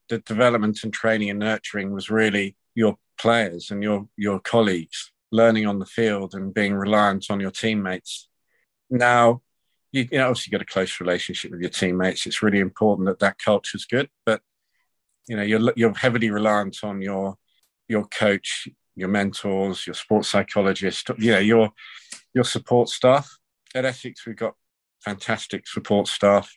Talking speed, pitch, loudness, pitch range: 165 wpm, 105 Hz, -22 LUFS, 100-115 Hz